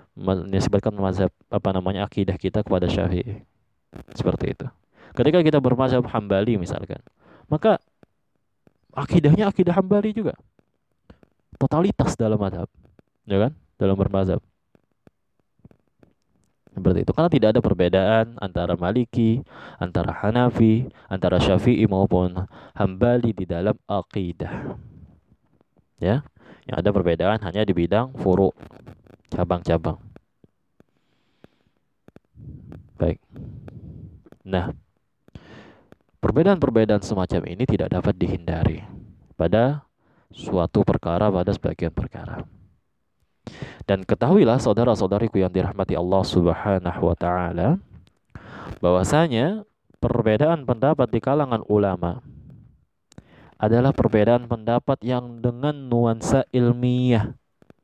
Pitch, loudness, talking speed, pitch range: 105 Hz, -22 LUFS, 90 wpm, 95-125 Hz